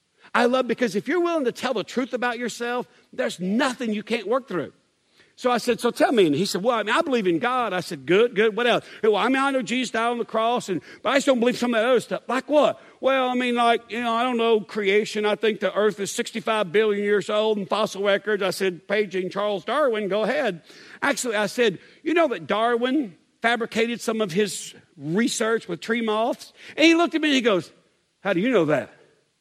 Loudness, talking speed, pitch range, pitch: -23 LUFS, 250 wpm, 210-250 Hz, 230 Hz